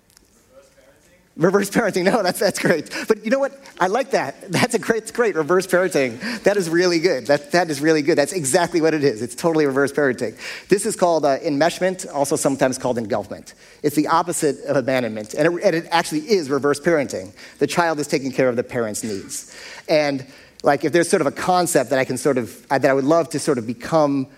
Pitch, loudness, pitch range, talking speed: 155 Hz, -20 LUFS, 140-180 Hz, 220 wpm